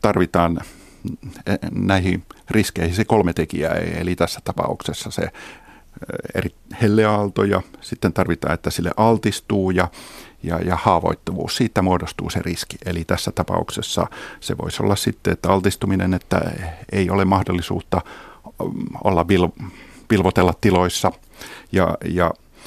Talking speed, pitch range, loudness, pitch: 120 wpm, 85-100 Hz, -21 LUFS, 90 Hz